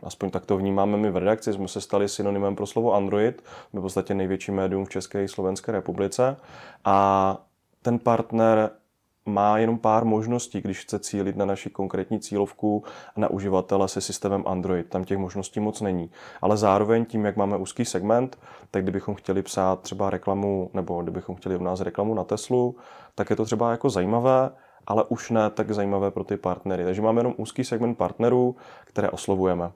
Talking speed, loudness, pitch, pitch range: 185 wpm, -25 LUFS, 100 Hz, 95-110 Hz